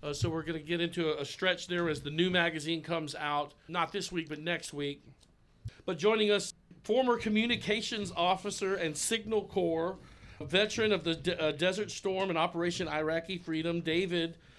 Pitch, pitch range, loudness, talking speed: 170 Hz, 160-195 Hz, -32 LUFS, 185 wpm